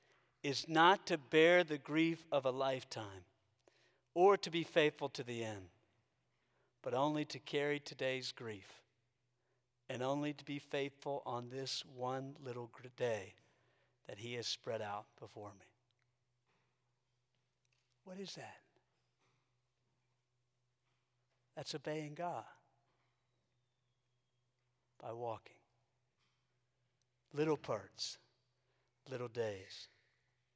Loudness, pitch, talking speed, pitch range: -38 LUFS, 125 Hz, 100 wpm, 120-140 Hz